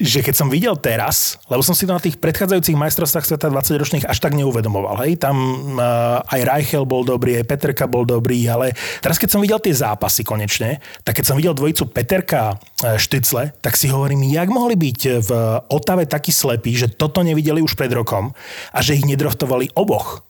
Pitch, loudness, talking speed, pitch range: 140 Hz, -17 LUFS, 195 wpm, 120-160 Hz